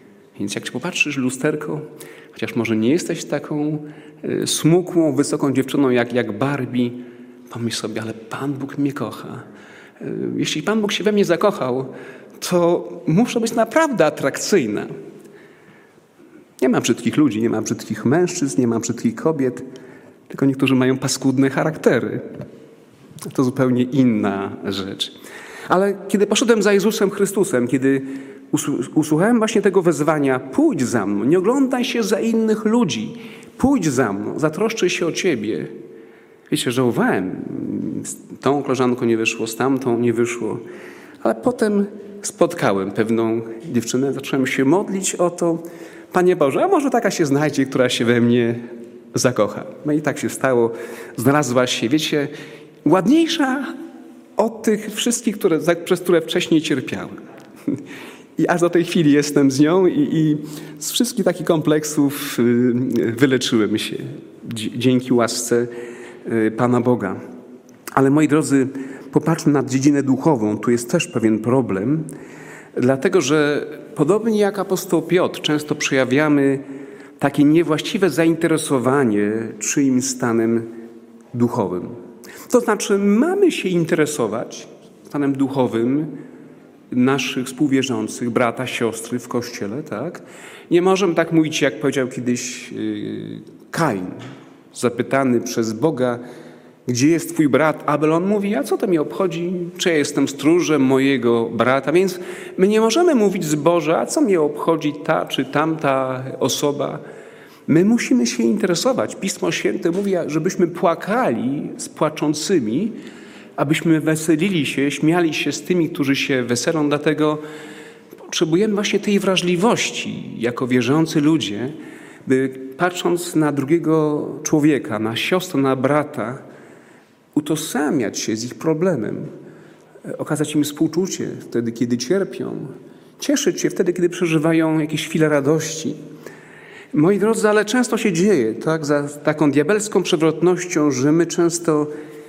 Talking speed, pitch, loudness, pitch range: 130 wpm, 150 Hz, -19 LUFS, 130-175 Hz